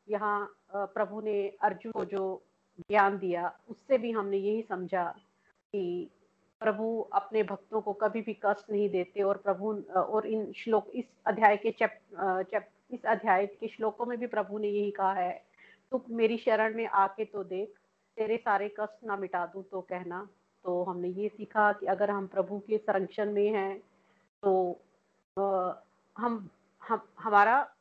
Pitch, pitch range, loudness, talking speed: 205 Hz, 195-215 Hz, -31 LUFS, 165 wpm